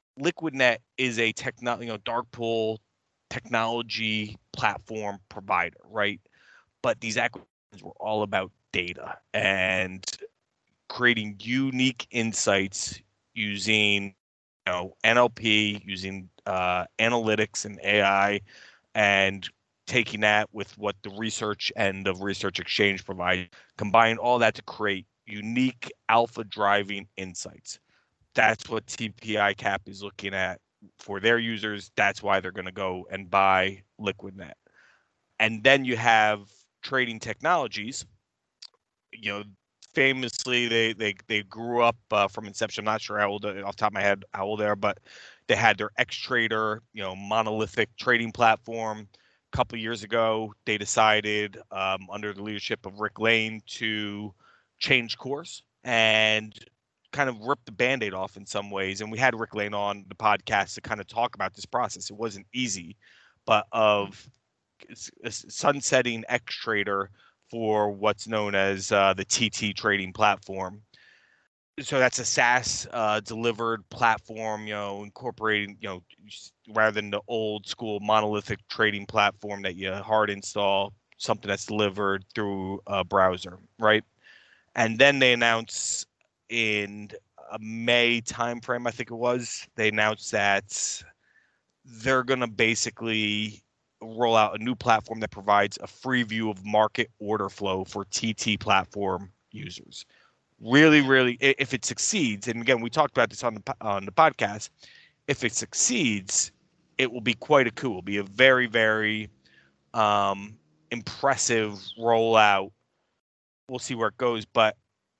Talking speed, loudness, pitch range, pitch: 145 wpm, -25 LUFS, 100-115 Hz, 110 Hz